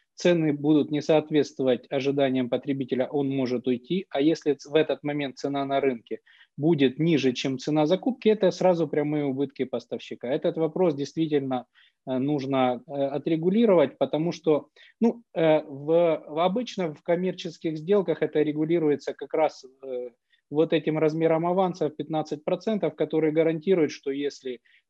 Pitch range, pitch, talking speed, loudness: 140-170 Hz, 155 Hz, 130 wpm, -25 LUFS